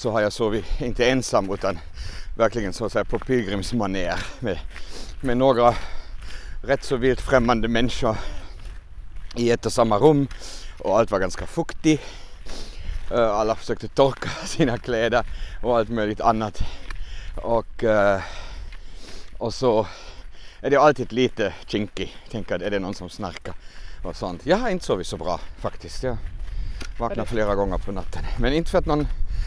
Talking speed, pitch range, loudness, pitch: 150 wpm, 90-120 Hz, -23 LUFS, 105 Hz